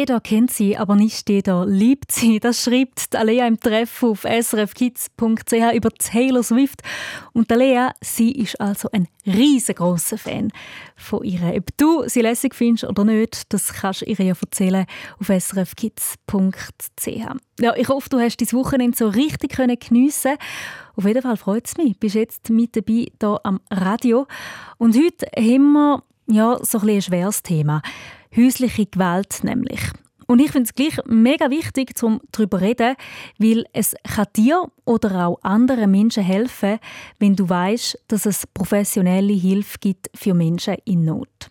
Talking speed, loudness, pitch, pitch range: 160 wpm, -19 LUFS, 225 Hz, 200-245 Hz